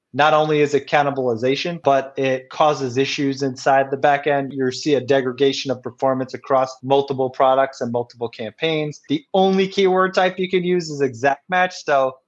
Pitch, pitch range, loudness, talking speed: 140 Hz, 130-150 Hz, -19 LUFS, 170 wpm